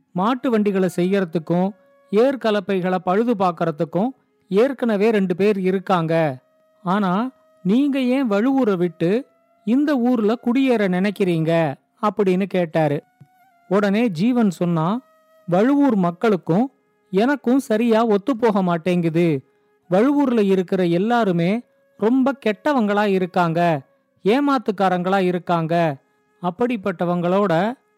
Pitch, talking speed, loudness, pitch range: 205 Hz, 80 wpm, -20 LUFS, 180-240 Hz